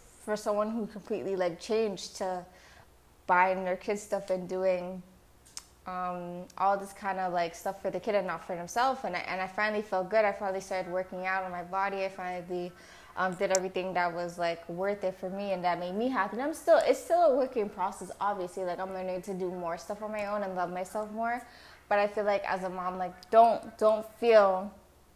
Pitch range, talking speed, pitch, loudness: 180-210 Hz, 220 wpm, 190 Hz, -31 LUFS